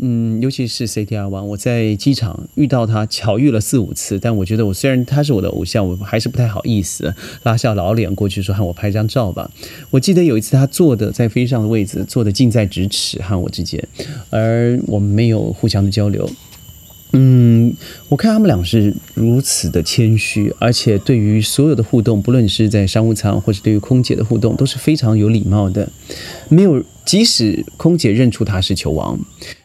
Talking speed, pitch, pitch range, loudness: 300 characters per minute, 110 Hz, 105-125 Hz, -15 LUFS